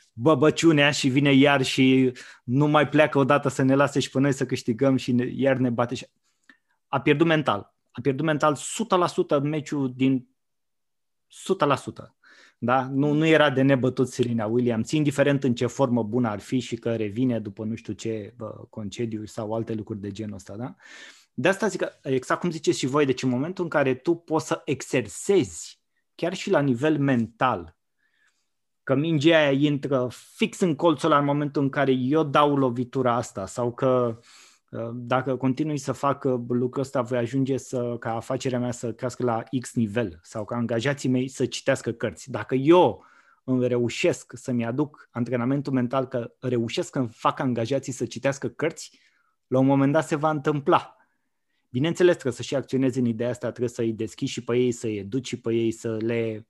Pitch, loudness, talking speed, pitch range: 130 Hz, -24 LUFS, 180 wpm, 120-145 Hz